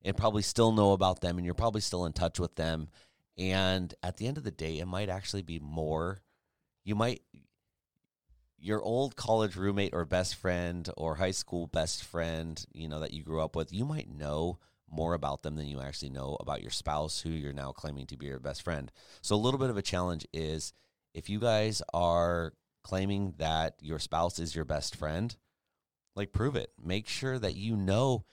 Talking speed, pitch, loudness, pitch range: 205 wpm, 90 Hz, -33 LUFS, 80-100 Hz